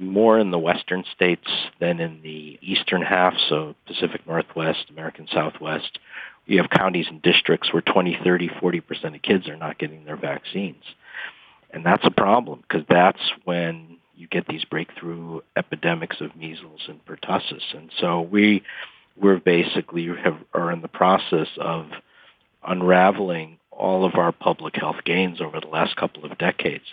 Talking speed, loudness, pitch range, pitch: 160 wpm, -22 LUFS, 80-90 Hz, 85 Hz